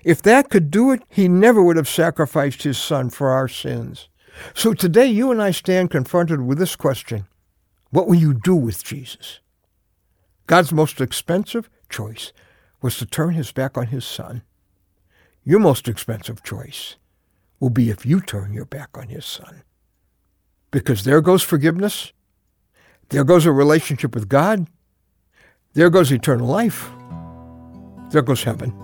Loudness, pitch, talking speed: -18 LUFS, 135 Hz, 155 wpm